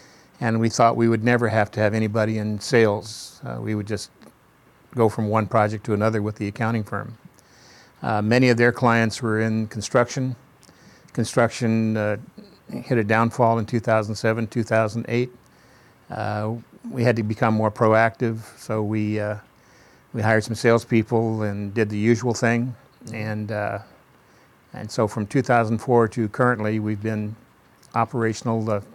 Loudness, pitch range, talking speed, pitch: -22 LUFS, 110-120 Hz, 150 wpm, 110 Hz